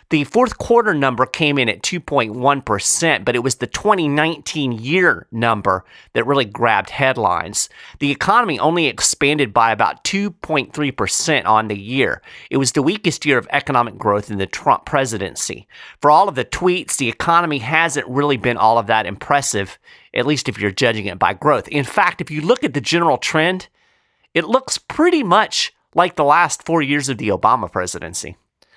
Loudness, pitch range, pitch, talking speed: -17 LUFS, 120-165 Hz, 145 Hz, 175 wpm